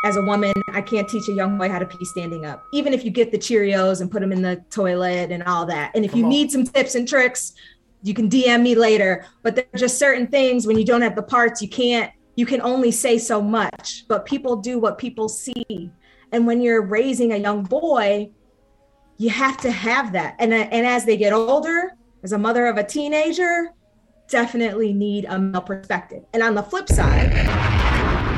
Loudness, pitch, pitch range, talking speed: -20 LUFS, 225 Hz, 200-245 Hz, 215 wpm